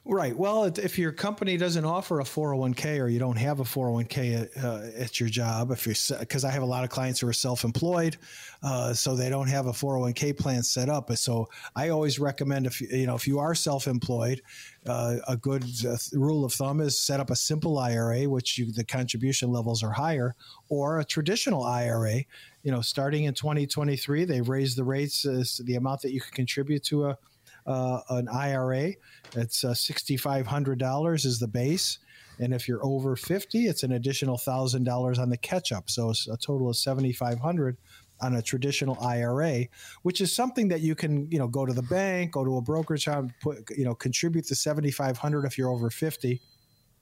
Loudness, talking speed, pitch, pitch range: -28 LUFS, 205 wpm, 135 Hz, 125-150 Hz